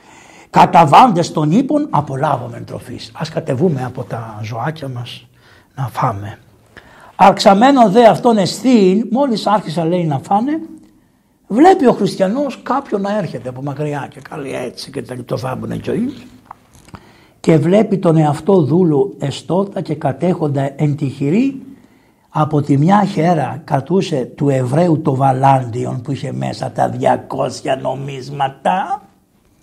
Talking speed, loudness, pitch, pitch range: 125 wpm, -15 LUFS, 160 Hz, 135-205 Hz